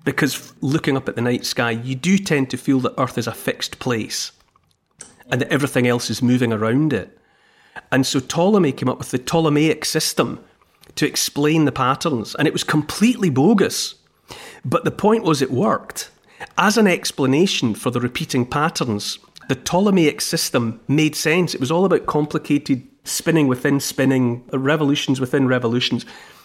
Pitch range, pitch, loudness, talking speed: 130-160 Hz, 140 Hz, -19 LUFS, 165 wpm